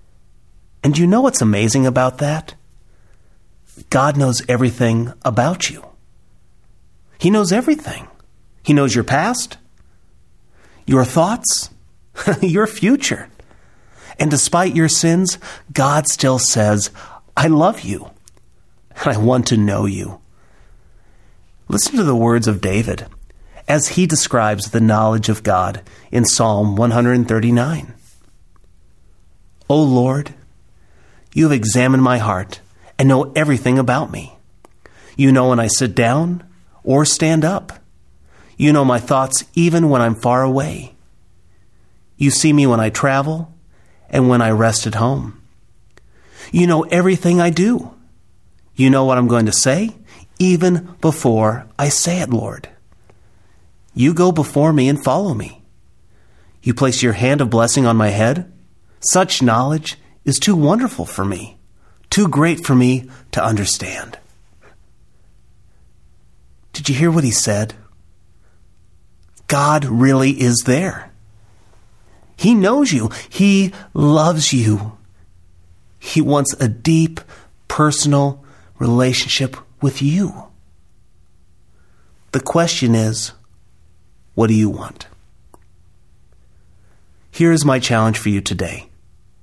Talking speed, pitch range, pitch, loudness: 120 wpm, 105-150 Hz, 125 Hz, -15 LUFS